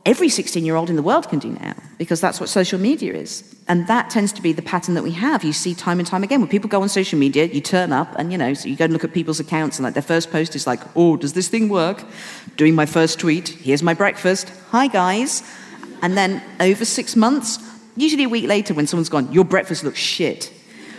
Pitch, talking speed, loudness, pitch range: 180 Hz, 255 wpm, -19 LUFS, 160-210 Hz